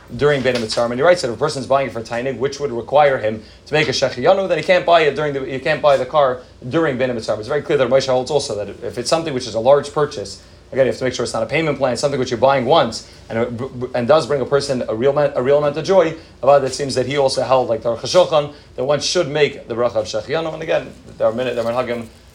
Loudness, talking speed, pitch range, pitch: -18 LUFS, 295 wpm, 120-145 Hz, 135 Hz